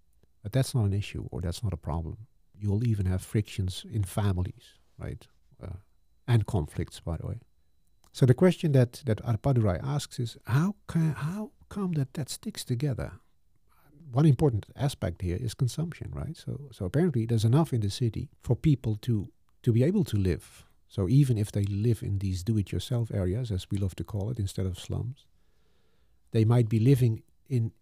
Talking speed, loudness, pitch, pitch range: 185 wpm, -29 LUFS, 115 Hz, 95-130 Hz